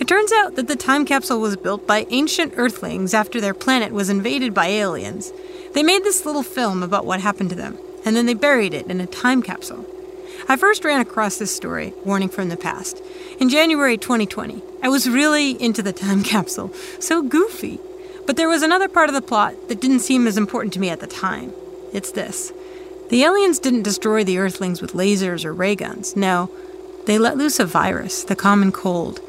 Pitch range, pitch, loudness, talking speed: 200-330 Hz, 245 Hz, -19 LUFS, 205 wpm